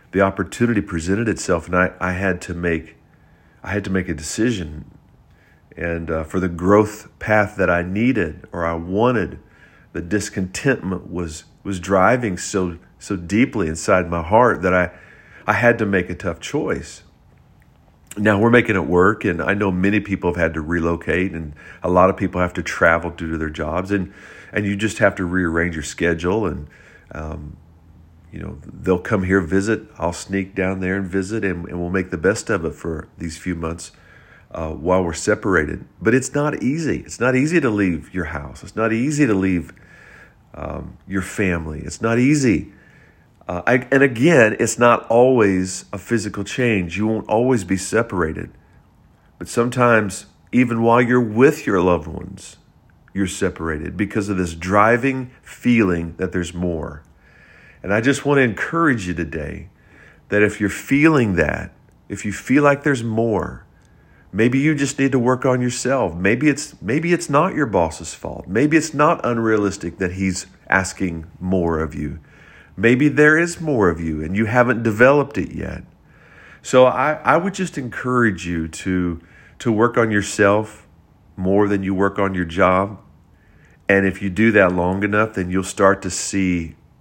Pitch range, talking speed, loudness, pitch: 85-115 Hz, 175 wpm, -19 LUFS, 95 Hz